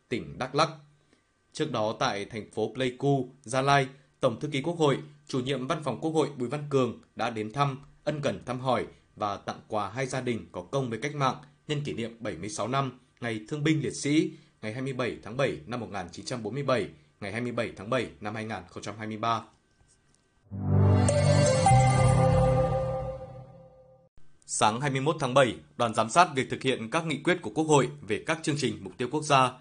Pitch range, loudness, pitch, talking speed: 115-145 Hz, -28 LUFS, 130 Hz, 180 wpm